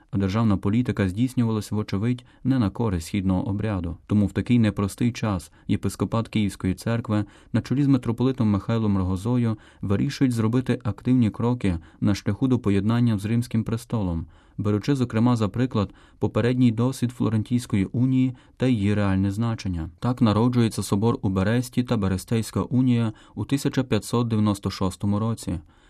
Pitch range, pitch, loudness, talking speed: 100-120 Hz, 110 Hz, -24 LUFS, 135 wpm